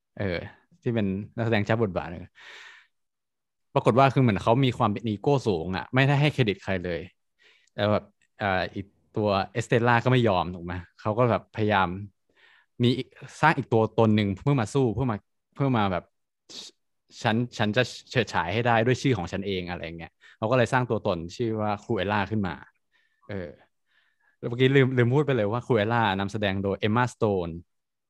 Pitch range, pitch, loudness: 100-125 Hz, 110 Hz, -25 LUFS